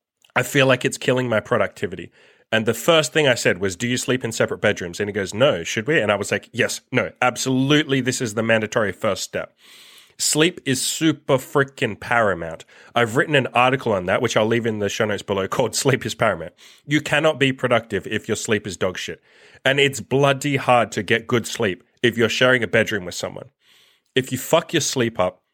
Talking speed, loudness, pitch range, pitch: 220 wpm, -20 LUFS, 115-140 Hz, 130 Hz